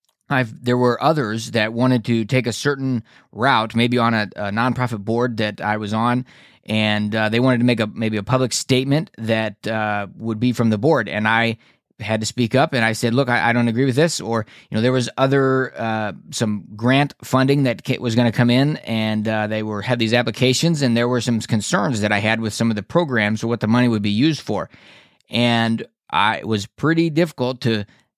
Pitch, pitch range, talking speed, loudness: 120 Hz, 110-130 Hz, 225 wpm, -19 LUFS